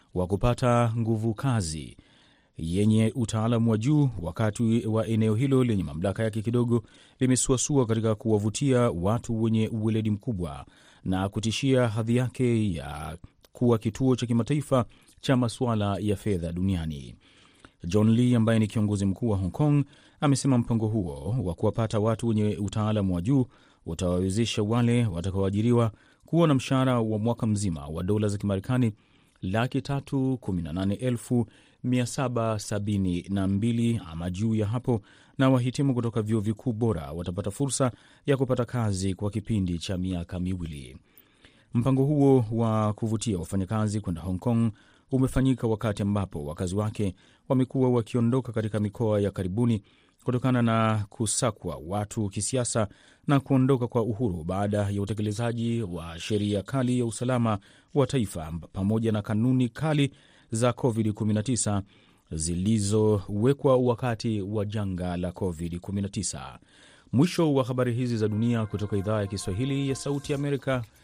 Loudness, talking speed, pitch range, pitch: -27 LUFS, 130 wpm, 100-125 Hz, 110 Hz